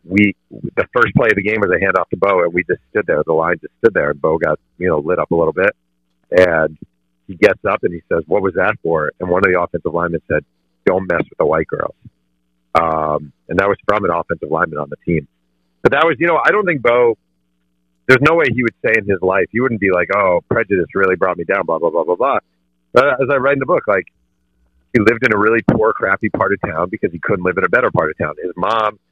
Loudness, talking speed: -16 LUFS, 265 wpm